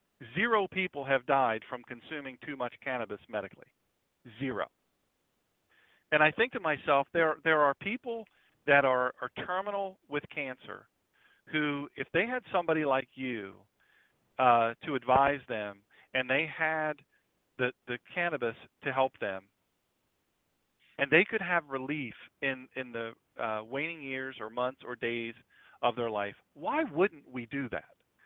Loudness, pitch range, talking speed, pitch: -31 LUFS, 125-160 Hz, 145 wpm, 135 Hz